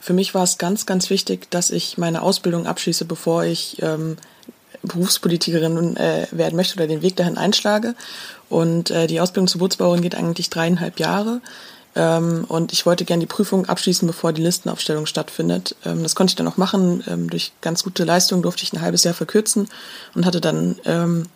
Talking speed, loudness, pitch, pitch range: 190 wpm, -19 LUFS, 175 Hz, 165-190 Hz